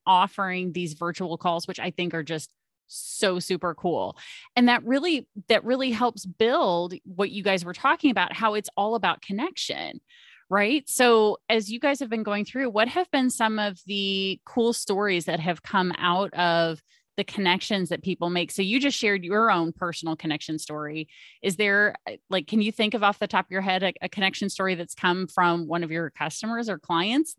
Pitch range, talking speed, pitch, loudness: 175-225 Hz, 200 wpm, 195 Hz, -25 LUFS